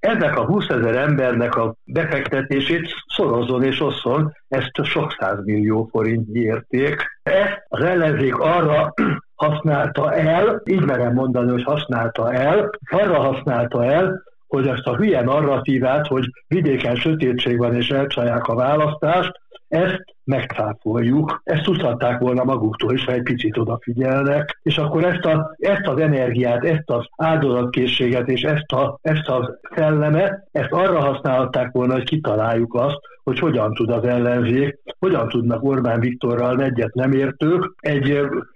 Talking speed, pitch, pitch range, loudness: 140 wpm, 135 Hz, 120-155 Hz, -19 LUFS